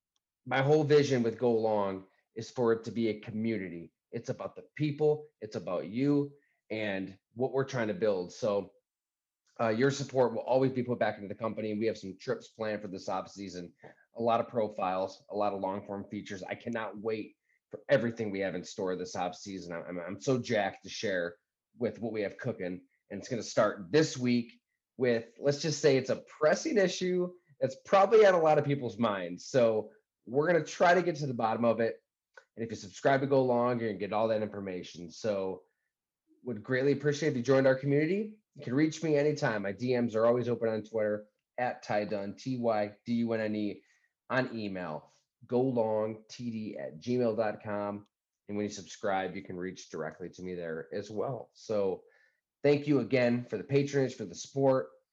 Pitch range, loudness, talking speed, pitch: 100-135 Hz, -31 LUFS, 205 wpm, 115 Hz